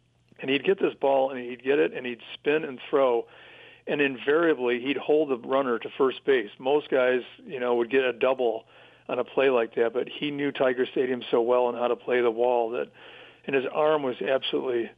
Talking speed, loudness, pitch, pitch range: 220 wpm, -26 LUFS, 135 Hz, 125-155 Hz